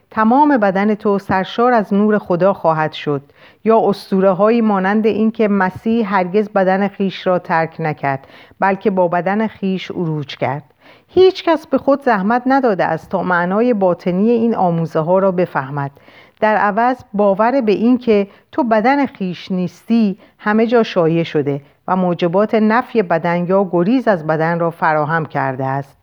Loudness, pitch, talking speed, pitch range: -16 LUFS, 195 Hz, 160 wpm, 170-220 Hz